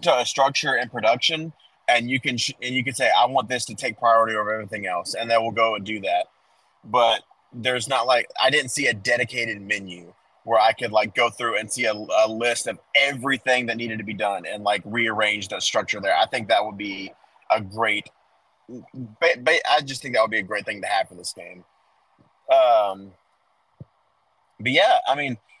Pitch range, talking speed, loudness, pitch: 105-130 Hz, 215 wpm, -22 LUFS, 115 Hz